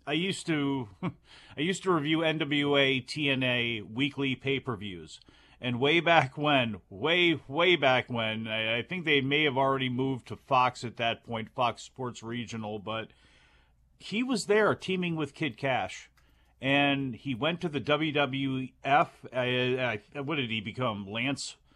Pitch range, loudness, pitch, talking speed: 115-150 Hz, -29 LUFS, 135 Hz, 160 wpm